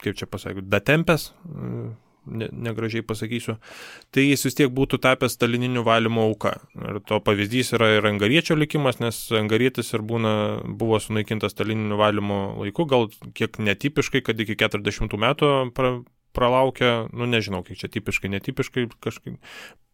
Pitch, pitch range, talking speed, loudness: 115 Hz, 105-130 Hz, 145 wpm, -23 LUFS